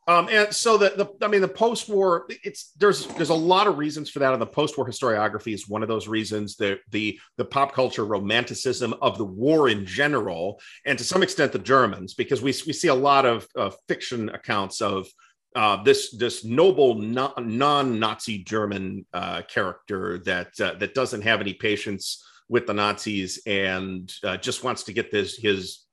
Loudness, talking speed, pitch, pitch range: -24 LUFS, 190 wpm, 120 Hz, 105-150 Hz